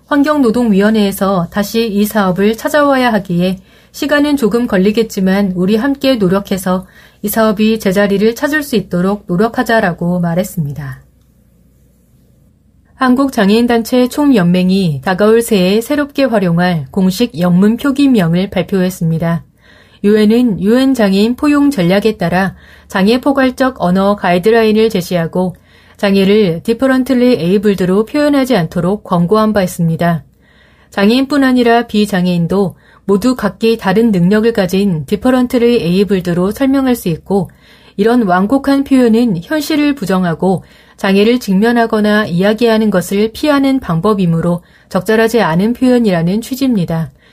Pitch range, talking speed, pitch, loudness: 185-240 Hz, 320 characters per minute, 210 Hz, -12 LUFS